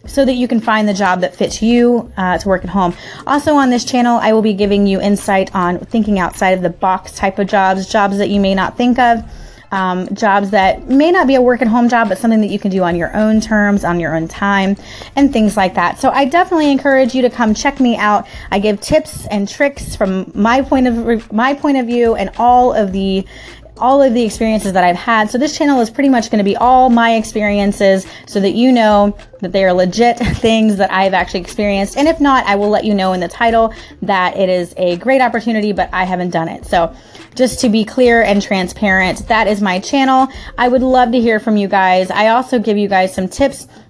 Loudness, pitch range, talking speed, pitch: -13 LUFS, 190-245 Hz, 240 wpm, 215 Hz